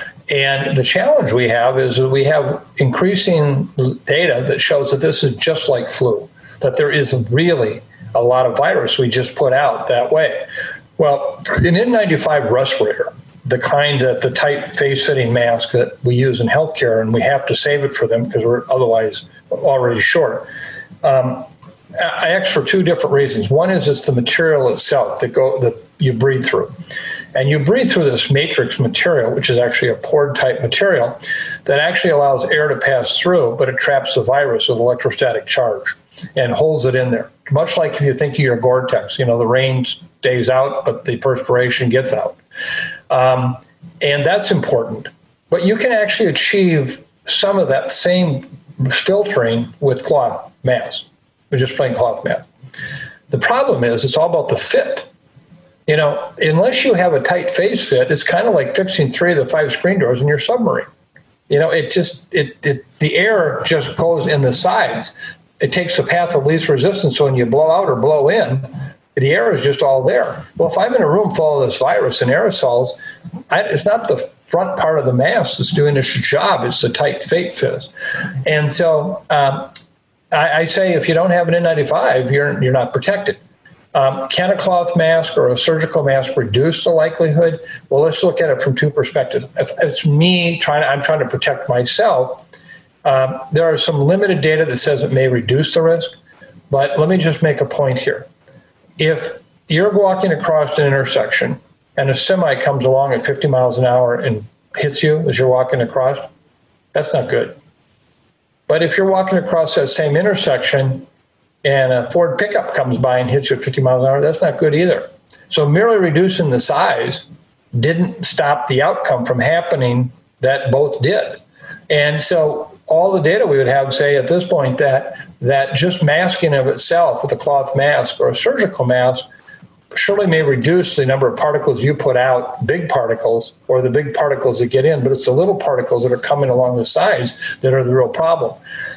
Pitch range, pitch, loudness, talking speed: 130-180 Hz, 145 Hz, -15 LUFS, 195 wpm